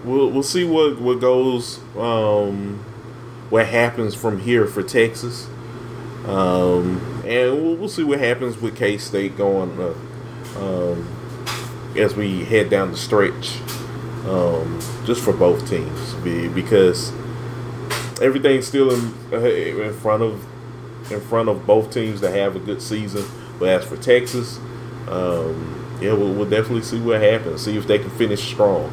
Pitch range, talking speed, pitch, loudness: 105-125 Hz, 150 wpm, 120 Hz, -20 LUFS